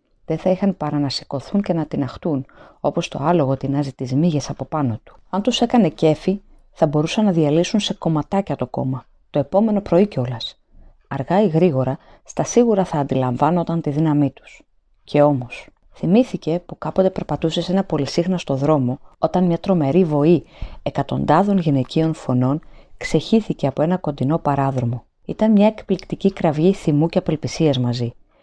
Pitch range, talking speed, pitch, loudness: 140-185 Hz, 155 wpm, 160 Hz, -19 LUFS